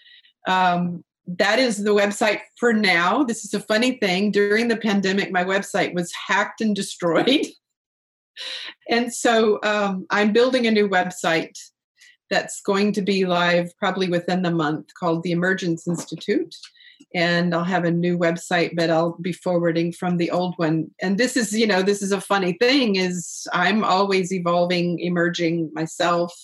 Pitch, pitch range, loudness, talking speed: 185 Hz, 175-210 Hz, -21 LUFS, 165 wpm